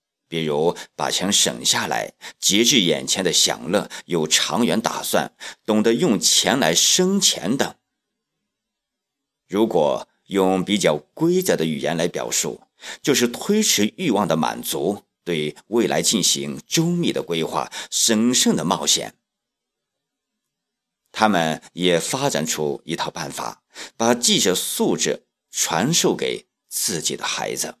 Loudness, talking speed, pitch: -20 LUFS, 190 characters per minute, 120 Hz